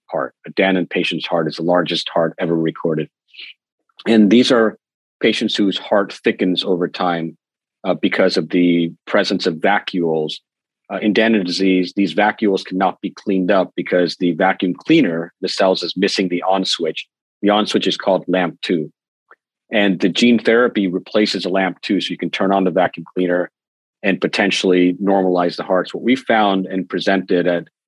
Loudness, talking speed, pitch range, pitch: -17 LUFS, 180 wpm, 85-100 Hz, 95 Hz